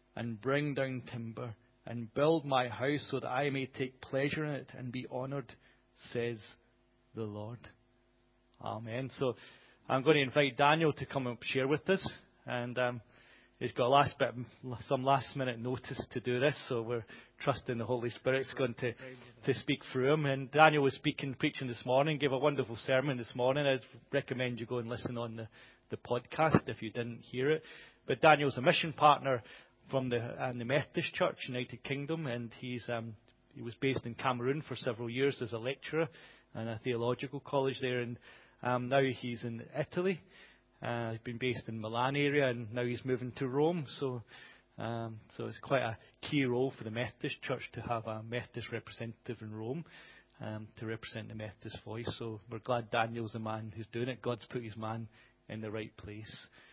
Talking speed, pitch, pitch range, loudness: 195 wpm, 125 Hz, 115-135 Hz, -35 LUFS